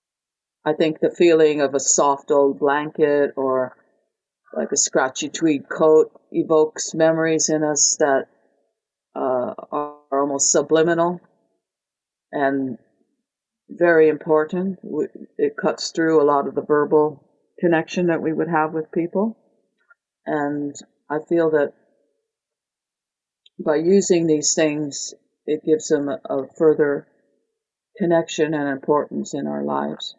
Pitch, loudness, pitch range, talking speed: 155 Hz, -20 LUFS, 145-165 Hz, 125 wpm